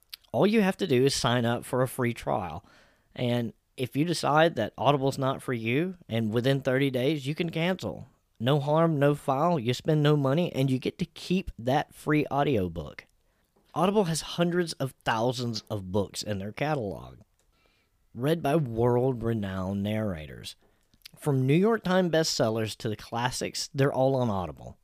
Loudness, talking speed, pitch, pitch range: -27 LUFS, 170 wpm, 130 Hz, 110-155 Hz